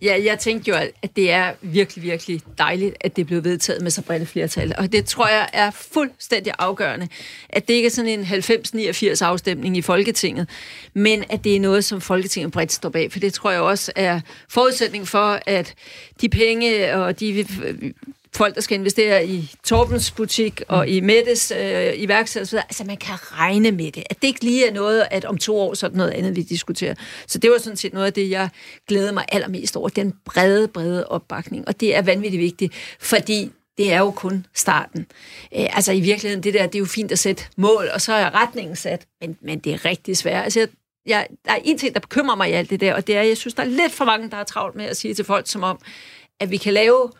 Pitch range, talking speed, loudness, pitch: 185-215 Hz, 235 wpm, -20 LUFS, 200 Hz